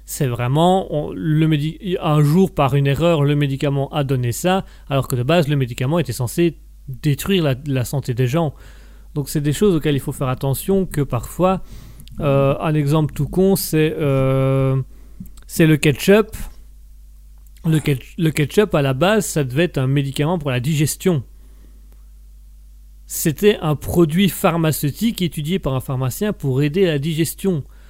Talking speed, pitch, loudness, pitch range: 170 wpm, 145 Hz, -18 LUFS, 130-165 Hz